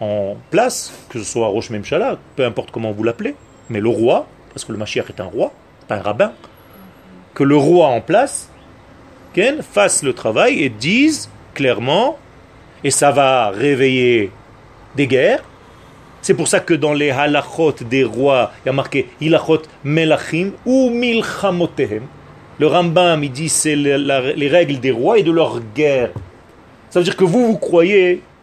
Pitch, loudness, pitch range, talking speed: 145 Hz, -16 LUFS, 130-170 Hz, 165 wpm